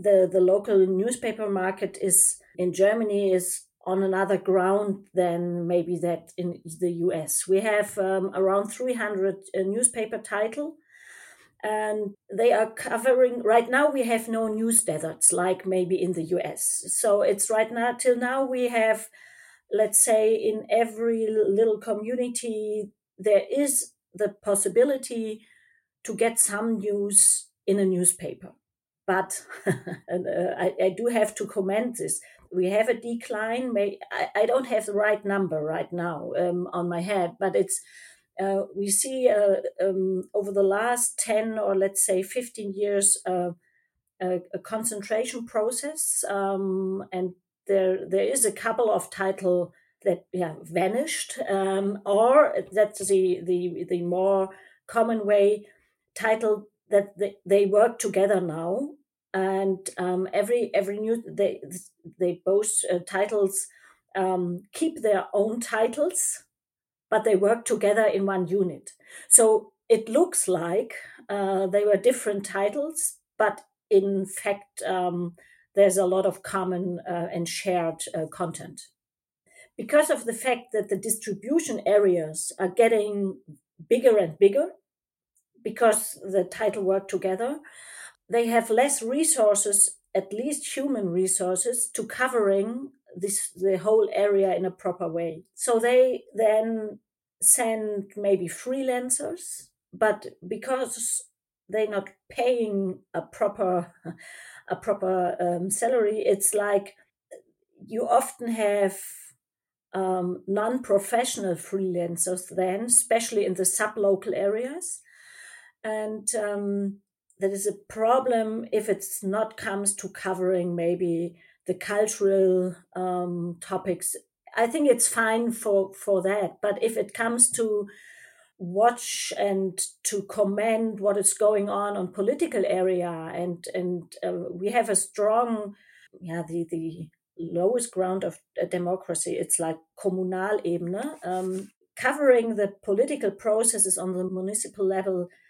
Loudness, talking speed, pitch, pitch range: -25 LUFS, 135 wpm, 200 Hz, 185-225 Hz